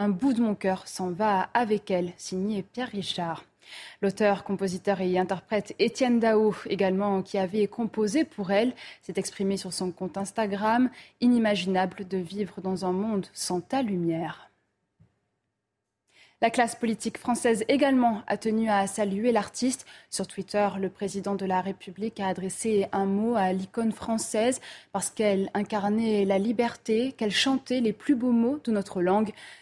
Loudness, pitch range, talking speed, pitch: -27 LUFS, 190-230 Hz, 155 wpm, 205 Hz